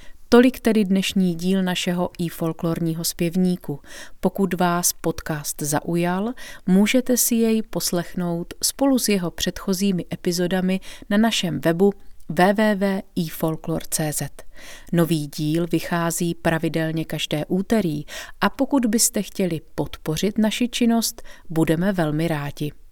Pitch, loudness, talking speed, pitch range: 180 Hz, -22 LUFS, 105 wpm, 165-205 Hz